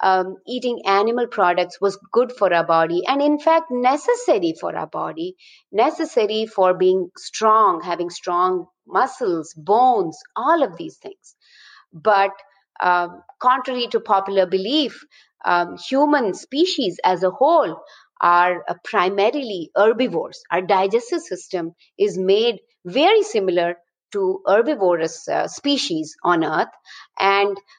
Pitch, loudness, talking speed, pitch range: 205 Hz, -19 LUFS, 125 wpm, 185-290 Hz